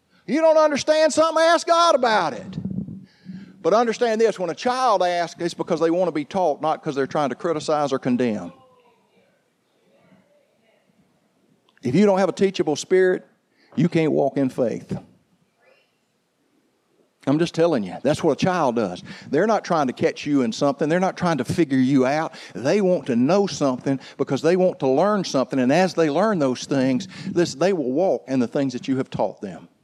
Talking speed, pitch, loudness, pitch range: 190 wpm, 170 Hz, -21 LUFS, 140-195 Hz